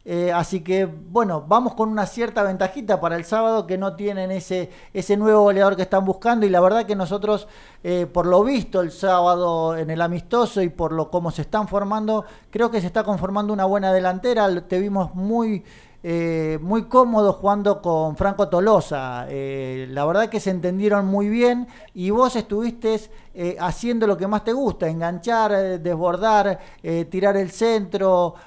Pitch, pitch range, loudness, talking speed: 195 Hz, 175-215 Hz, -21 LUFS, 180 wpm